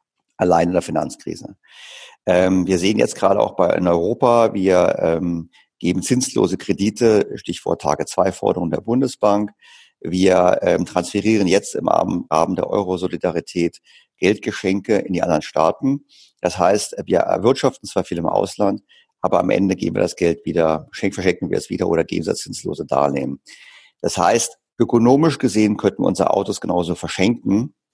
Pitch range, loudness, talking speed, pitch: 90-130 Hz, -19 LUFS, 150 wpm, 105 Hz